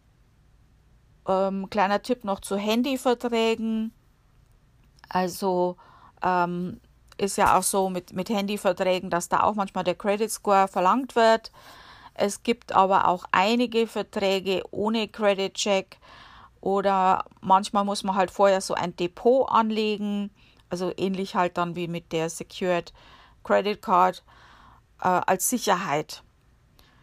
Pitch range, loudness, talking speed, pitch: 180-210 Hz, -25 LUFS, 120 wpm, 195 Hz